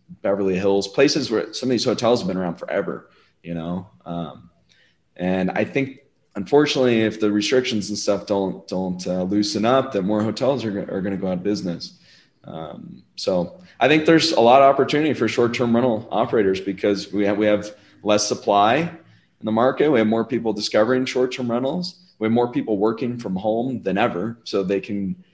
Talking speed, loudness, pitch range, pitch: 195 wpm, -21 LUFS, 100-125 Hz, 105 Hz